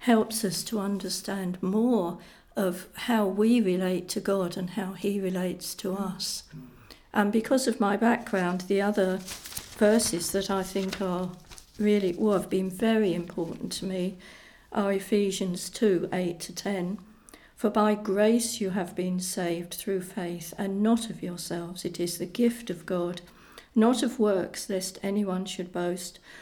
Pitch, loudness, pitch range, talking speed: 195 Hz, -28 LUFS, 180-210 Hz, 160 wpm